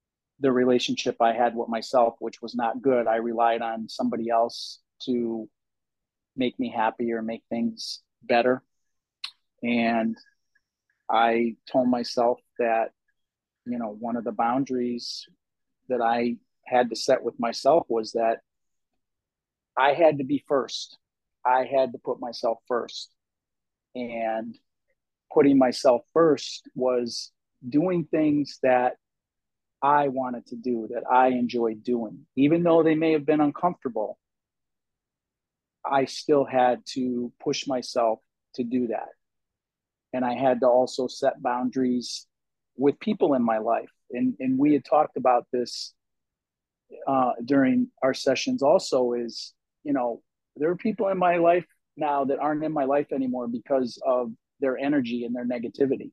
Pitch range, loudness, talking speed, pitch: 120-140 Hz, -25 LUFS, 140 wpm, 125 Hz